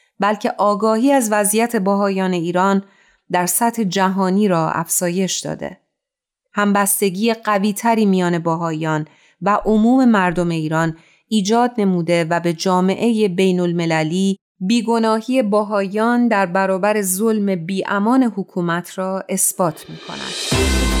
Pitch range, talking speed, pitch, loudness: 175-215 Hz, 110 wpm, 195 Hz, -17 LUFS